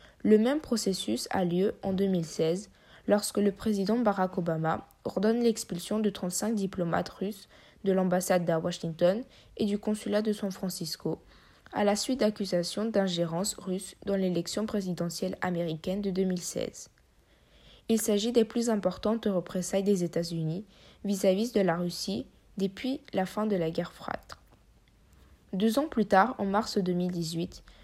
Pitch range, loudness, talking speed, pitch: 175-215 Hz, -30 LUFS, 140 wpm, 195 Hz